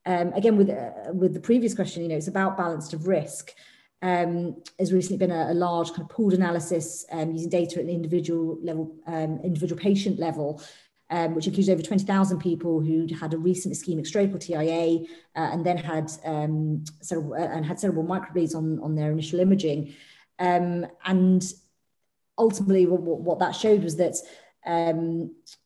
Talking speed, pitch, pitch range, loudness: 180 wpm, 170 Hz, 160-185 Hz, -26 LUFS